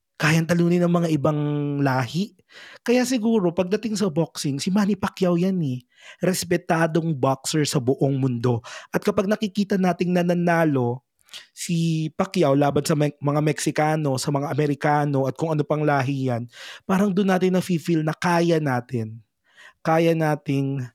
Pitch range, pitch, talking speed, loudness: 140-180 Hz, 160 Hz, 145 wpm, -22 LUFS